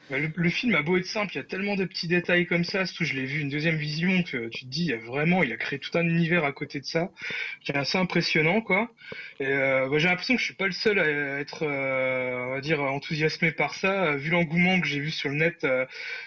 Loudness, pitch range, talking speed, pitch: -26 LUFS, 140-180 Hz, 275 wpm, 165 Hz